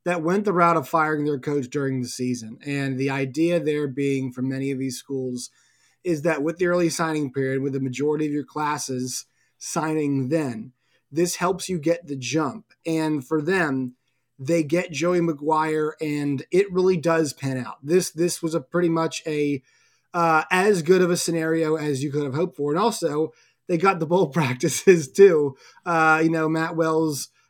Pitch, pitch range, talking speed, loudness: 155 Hz, 140-170 Hz, 190 wpm, -23 LUFS